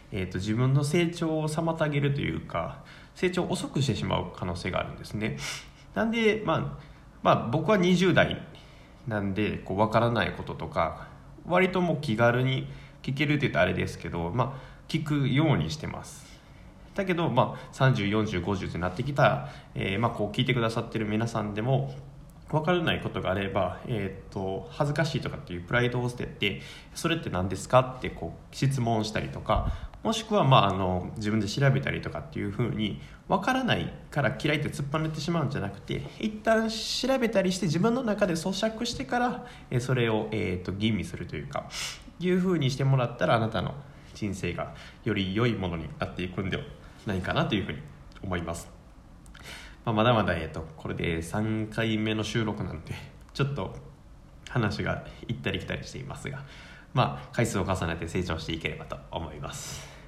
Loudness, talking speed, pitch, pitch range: -28 LUFS, 365 characters per minute, 120 Hz, 100-155 Hz